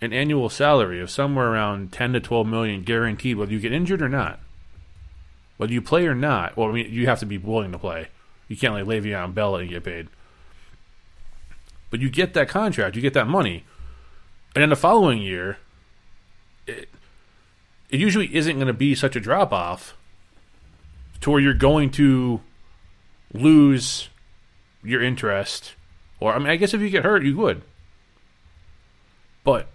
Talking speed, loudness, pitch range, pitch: 175 wpm, -21 LUFS, 90-135 Hz, 110 Hz